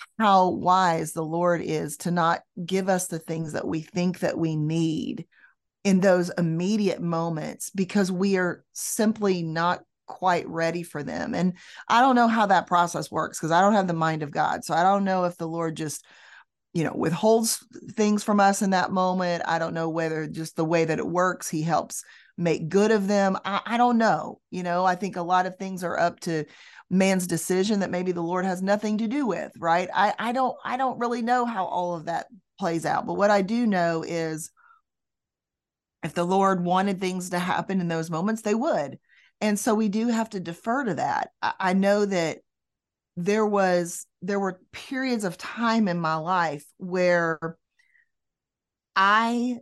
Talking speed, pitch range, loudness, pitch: 195 wpm, 170-205 Hz, -25 LUFS, 185 Hz